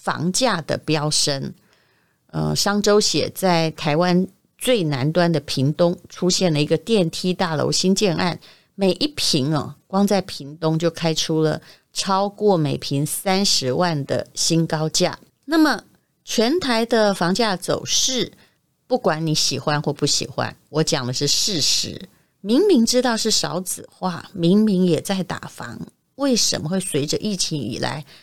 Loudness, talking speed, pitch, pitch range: -20 LUFS, 215 characters per minute, 175 Hz, 155-200 Hz